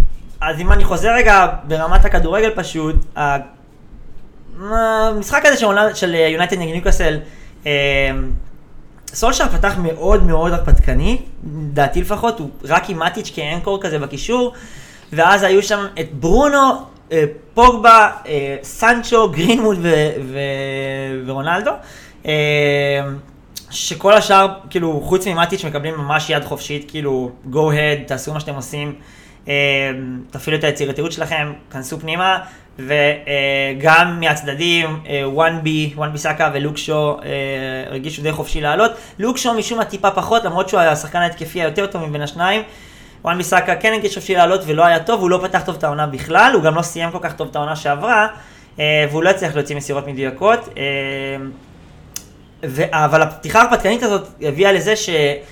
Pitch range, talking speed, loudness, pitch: 145-190 Hz, 145 wpm, -16 LUFS, 155 Hz